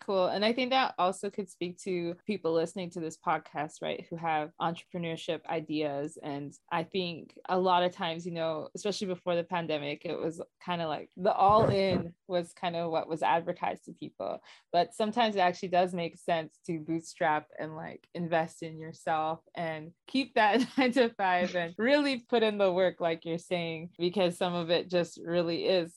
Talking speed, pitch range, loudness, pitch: 195 wpm, 165-185 Hz, -31 LUFS, 175 Hz